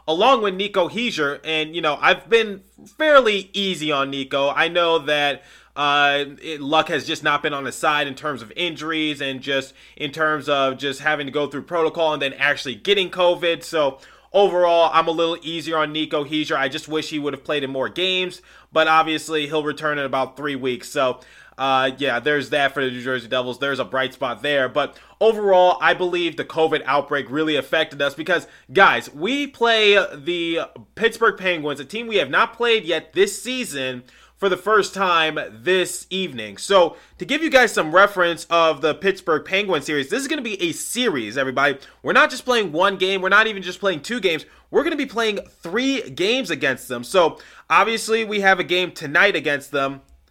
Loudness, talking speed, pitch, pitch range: -20 LUFS, 205 wpm, 160 Hz, 145-195 Hz